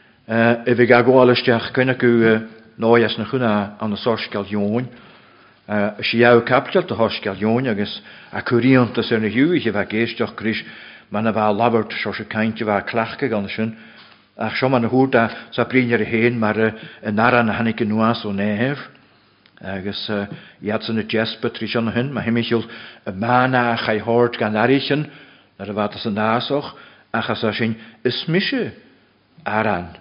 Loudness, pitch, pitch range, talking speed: -19 LUFS, 115 Hz, 110-120 Hz, 165 wpm